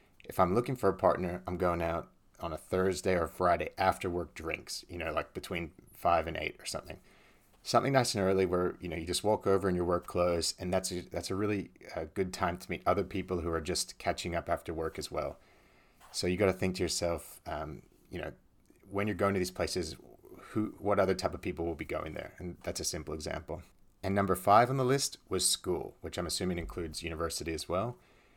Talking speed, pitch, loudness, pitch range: 230 wpm, 90 Hz, -33 LUFS, 85-95 Hz